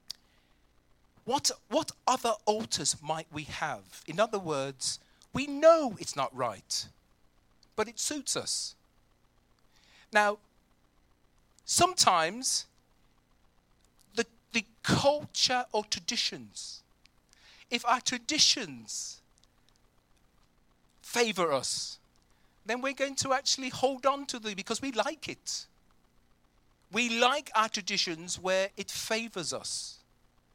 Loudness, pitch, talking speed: -30 LUFS, 160 Hz, 100 wpm